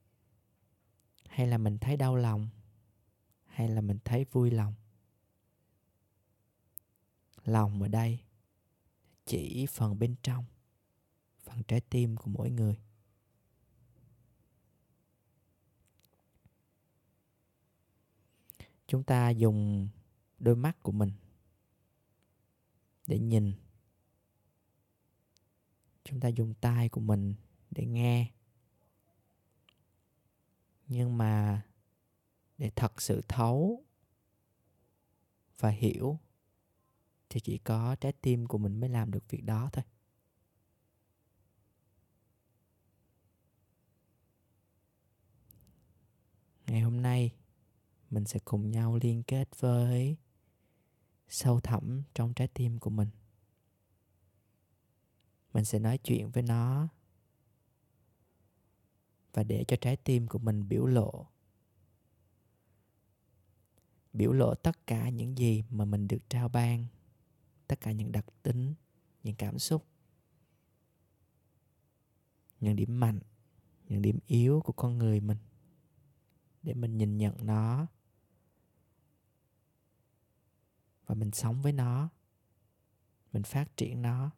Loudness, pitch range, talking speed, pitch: -32 LUFS, 105-120 Hz, 100 wpm, 110 Hz